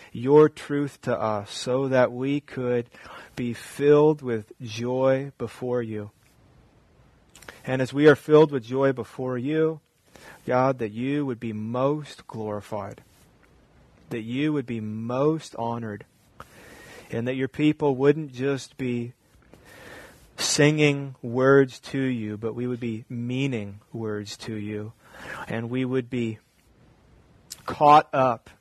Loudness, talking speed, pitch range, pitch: -24 LUFS, 130 wpm, 115-140 Hz, 125 Hz